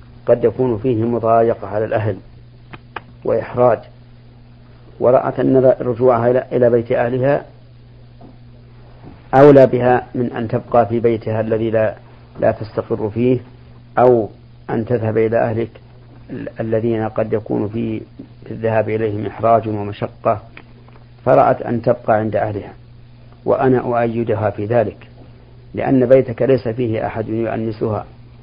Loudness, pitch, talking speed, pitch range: -17 LUFS, 120 Hz, 110 wpm, 110-120 Hz